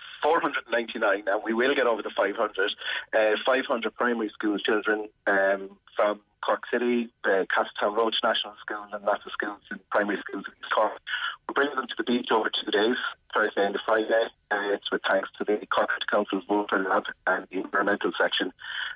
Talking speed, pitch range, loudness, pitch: 190 wpm, 105-120 Hz, -26 LUFS, 110 Hz